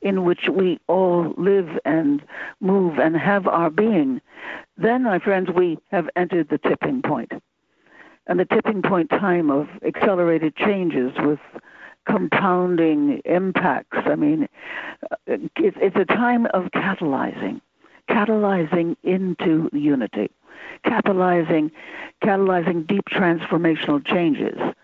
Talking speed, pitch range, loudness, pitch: 110 wpm, 170-230 Hz, -21 LUFS, 185 Hz